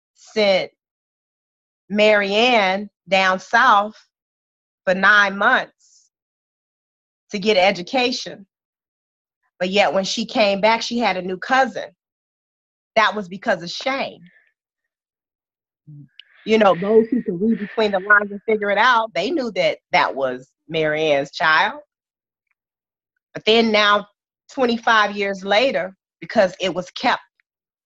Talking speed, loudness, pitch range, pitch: 120 wpm, -18 LUFS, 185-225 Hz, 205 Hz